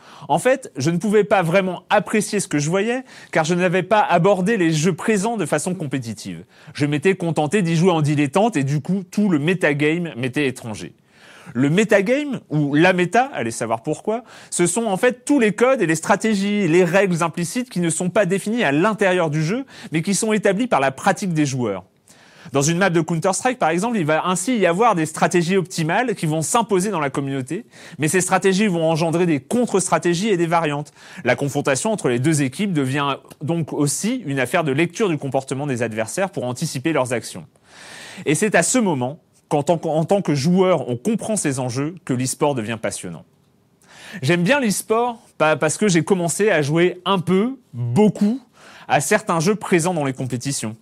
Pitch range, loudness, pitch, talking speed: 150-205 Hz, -19 LUFS, 175 Hz, 195 wpm